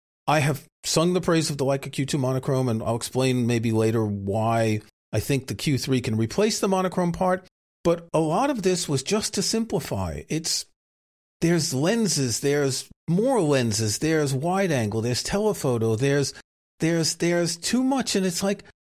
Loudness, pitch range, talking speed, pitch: -24 LUFS, 115-180 Hz, 170 wpm, 140 Hz